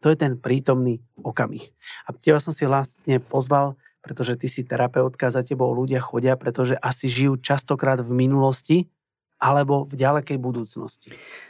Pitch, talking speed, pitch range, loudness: 130 Hz, 150 wpm, 125-140 Hz, -22 LUFS